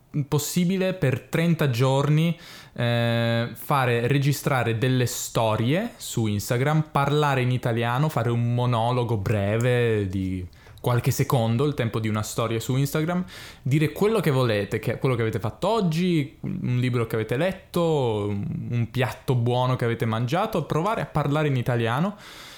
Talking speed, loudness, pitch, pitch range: 145 wpm, -24 LUFS, 130 Hz, 115-150 Hz